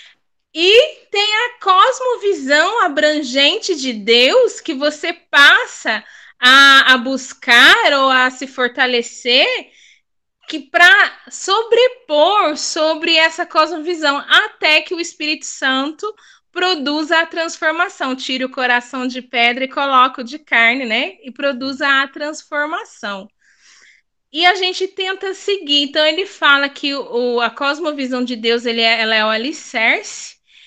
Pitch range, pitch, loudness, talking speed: 260-355 Hz, 300 Hz, -14 LUFS, 130 wpm